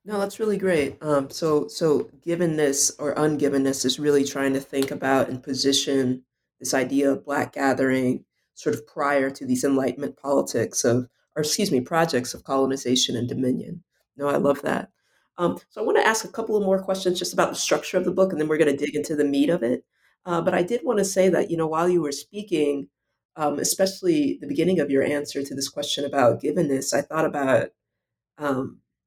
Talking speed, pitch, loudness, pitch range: 210 wpm, 145 Hz, -23 LUFS, 135-175 Hz